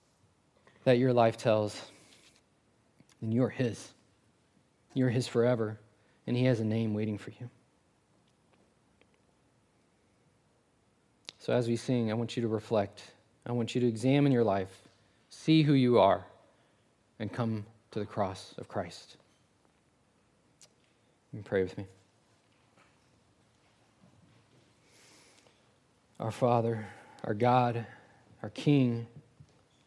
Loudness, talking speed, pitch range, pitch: -30 LUFS, 110 wpm, 110-125 Hz, 115 Hz